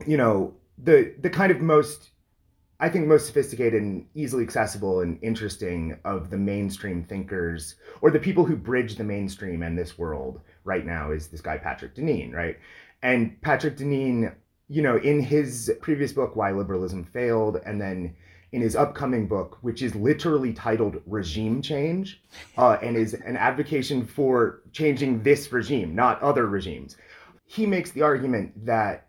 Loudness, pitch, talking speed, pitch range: -25 LUFS, 115 Hz, 165 wpm, 95-145 Hz